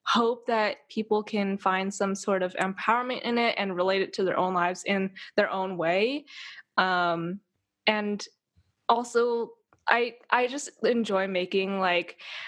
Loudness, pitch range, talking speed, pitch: -27 LUFS, 190-235 Hz, 150 wpm, 205 Hz